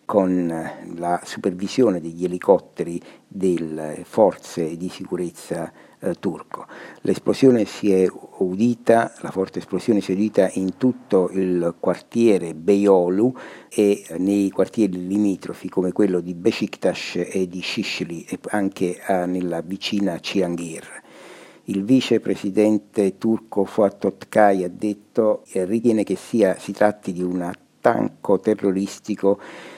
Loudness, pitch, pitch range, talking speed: -21 LUFS, 95 Hz, 90-105 Hz, 115 wpm